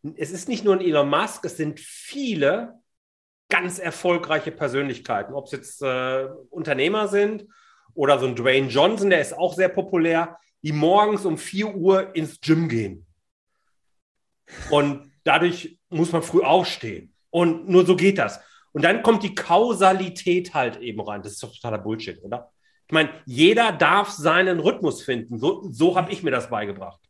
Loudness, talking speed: -21 LUFS, 170 wpm